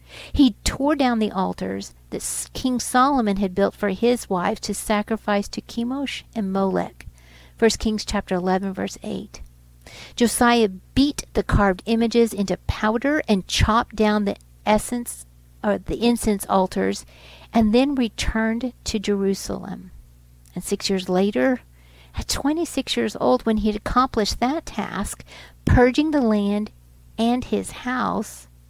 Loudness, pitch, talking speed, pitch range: -22 LUFS, 210 Hz, 140 wpm, 185-235 Hz